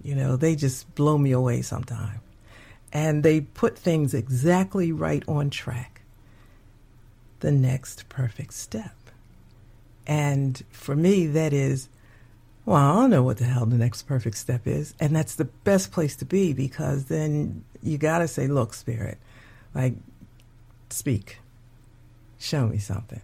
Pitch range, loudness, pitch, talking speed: 115-145 Hz, -25 LUFS, 125 Hz, 145 wpm